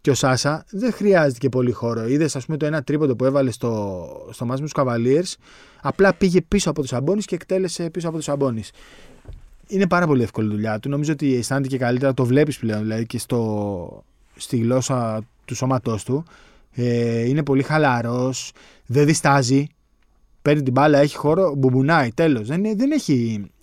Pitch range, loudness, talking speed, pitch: 120-155 Hz, -20 LUFS, 175 wpm, 135 Hz